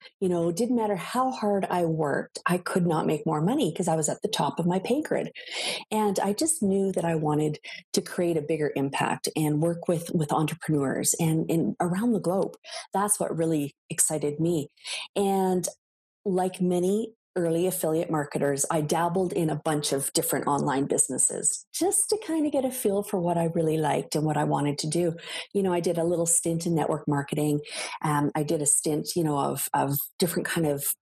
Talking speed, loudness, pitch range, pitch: 205 wpm, -26 LUFS, 155-190 Hz, 170 Hz